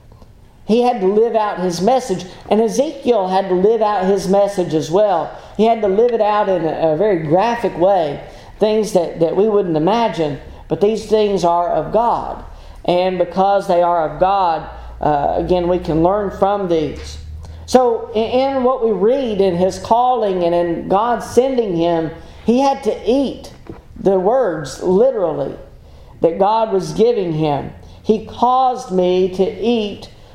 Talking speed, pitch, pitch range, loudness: 165 wpm, 195 Hz, 175-225 Hz, -16 LUFS